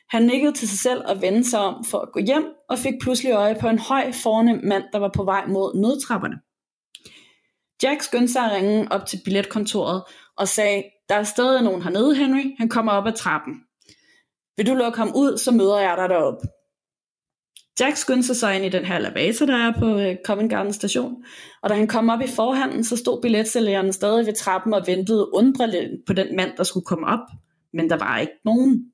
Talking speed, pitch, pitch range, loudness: 210 wpm, 220 Hz, 195-250 Hz, -21 LUFS